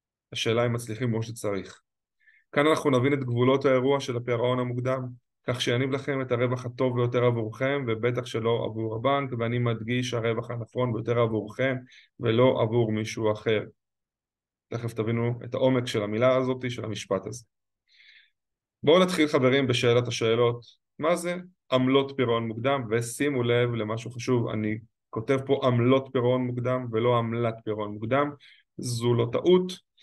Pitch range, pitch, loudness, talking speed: 115-130 Hz, 120 Hz, -26 LUFS, 145 wpm